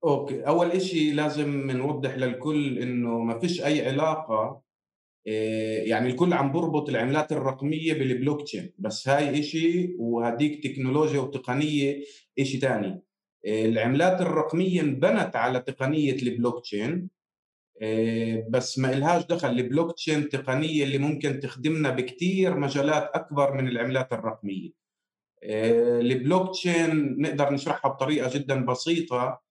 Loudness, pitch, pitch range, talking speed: -26 LUFS, 140 Hz, 125-155 Hz, 125 wpm